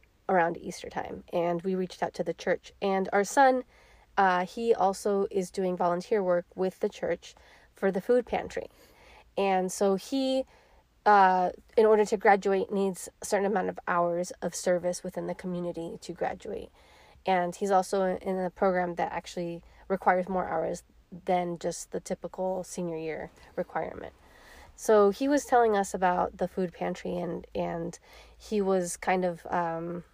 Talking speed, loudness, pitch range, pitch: 165 wpm, -29 LUFS, 175-200 Hz, 185 Hz